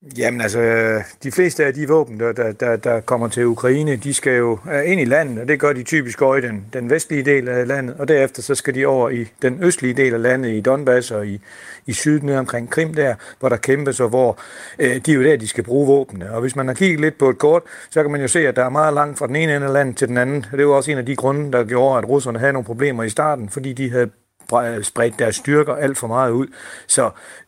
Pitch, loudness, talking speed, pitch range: 130 Hz, -18 LUFS, 265 wpm, 120-145 Hz